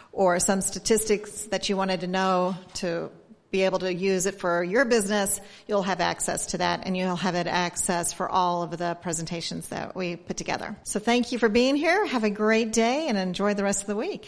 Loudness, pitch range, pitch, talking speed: -25 LUFS, 180-210 Hz, 190 Hz, 225 wpm